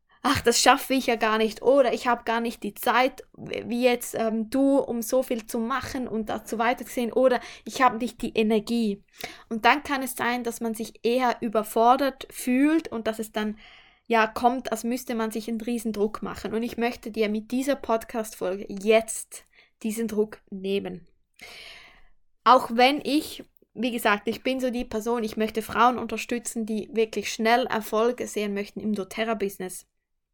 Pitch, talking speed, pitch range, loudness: 230 Hz, 175 wpm, 220-245 Hz, -25 LUFS